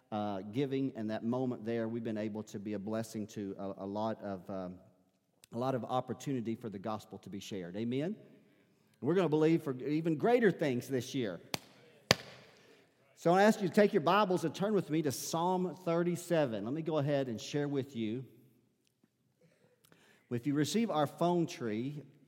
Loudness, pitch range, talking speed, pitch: -34 LUFS, 110-160 Hz, 190 wpm, 130 Hz